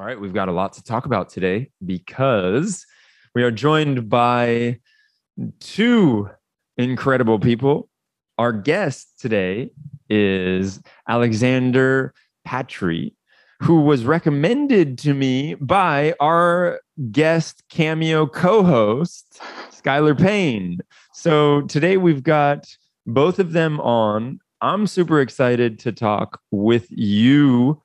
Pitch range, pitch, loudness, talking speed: 120-160 Hz, 140 Hz, -19 LUFS, 110 wpm